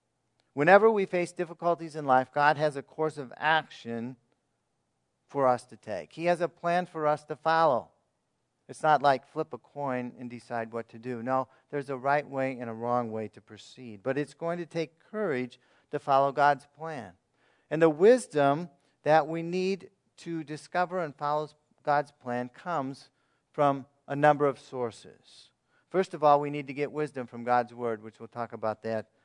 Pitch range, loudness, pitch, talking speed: 125-155 Hz, -29 LUFS, 145 Hz, 185 wpm